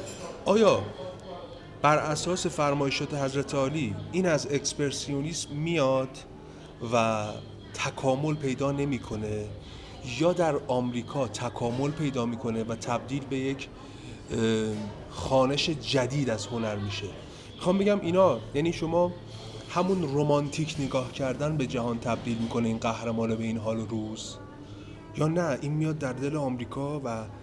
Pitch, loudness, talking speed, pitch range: 130 Hz, -28 LUFS, 125 wpm, 115-145 Hz